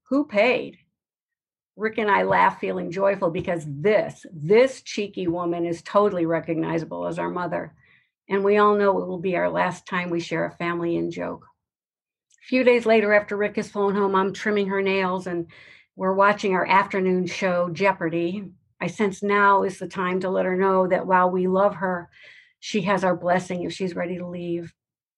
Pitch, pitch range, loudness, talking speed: 185 Hz, 175-200 Hz, -23 LUFS, 190 wpm